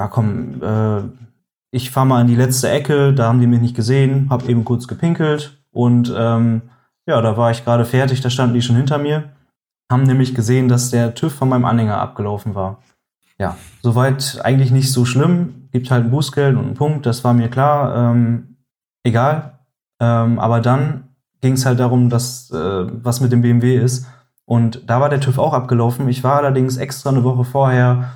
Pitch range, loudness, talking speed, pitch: 120-135 Hz, -16 LUFS, 195 wpm, 125 Hz